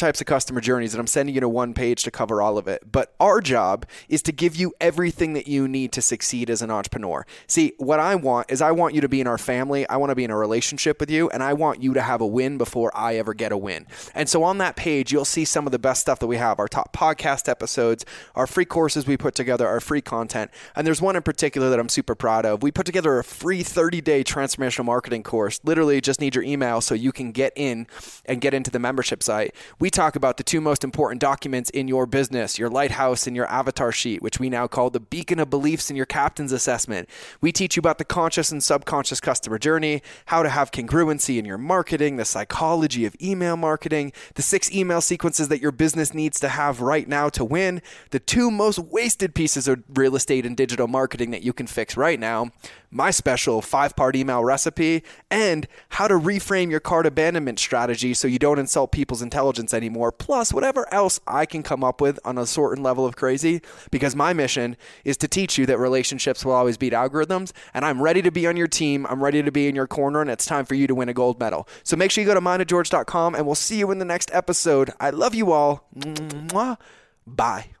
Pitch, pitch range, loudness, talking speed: 140 Hz, 125-160 Hz, -22 LUFS, 235 wpm